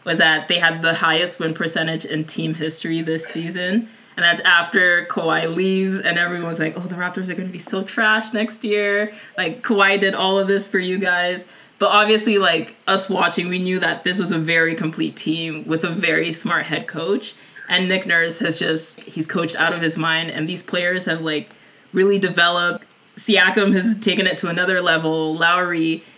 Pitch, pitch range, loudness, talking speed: 180 Hz, 165-195 Hz, -19 LUFS, 195 wpm